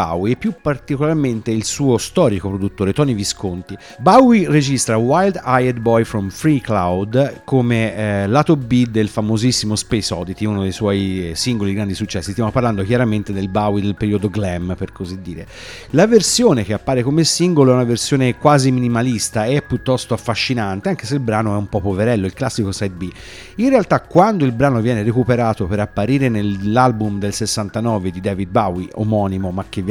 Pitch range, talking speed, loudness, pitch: 100-130 Hz, 175 wpm, -17 LUFS, 110 Hz